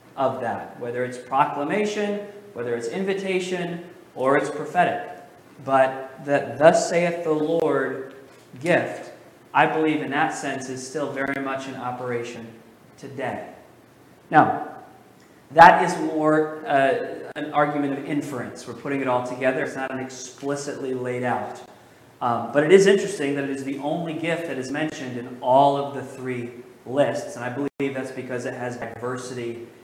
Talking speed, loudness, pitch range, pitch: 155 wpm, -23 LUFS, 125-155 Hz, 135 Hz